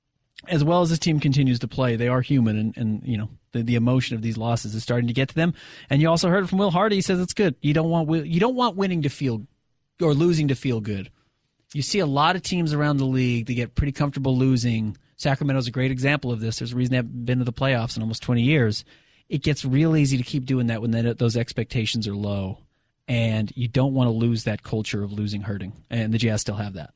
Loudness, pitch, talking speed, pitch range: -23 LUFS, 125 Hz, 260 wpm, 115-150 Hz